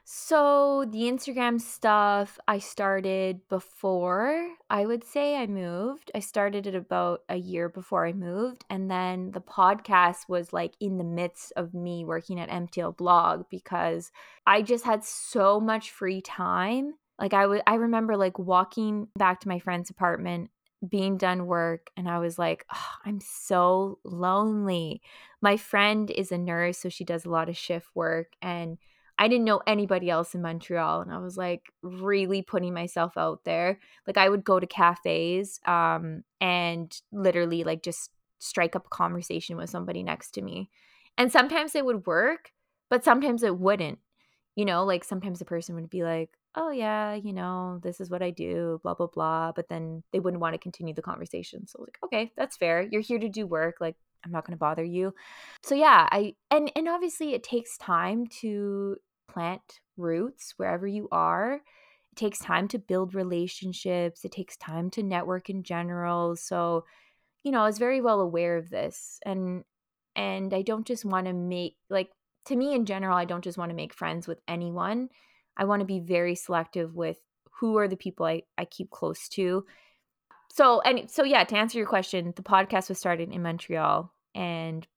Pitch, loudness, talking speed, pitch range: 185 Hz, -28 LUFS, 185 wpm, 175-210 Hz